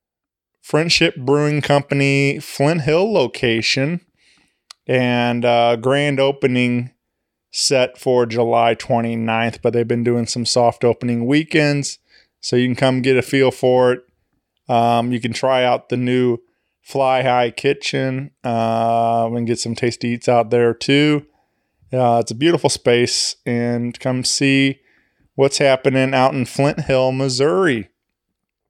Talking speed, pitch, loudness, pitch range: 135 wpm, 125 Hz, -17 LUFS, 120-140 Hz